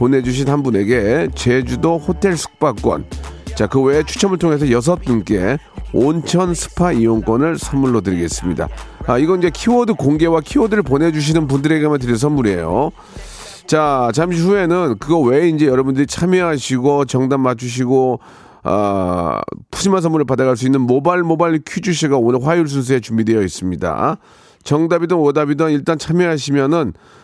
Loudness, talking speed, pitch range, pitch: -16 LUFS, 355 characters per minute, 125-165 Hz, 145 Hz